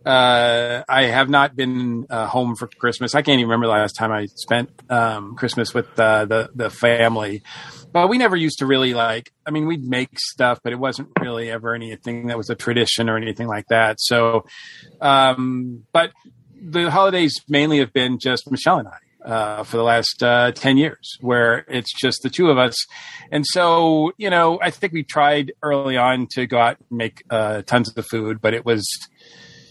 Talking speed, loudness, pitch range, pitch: 200 wpm, -19 LUFS, 115-140 Hz, 125 Hz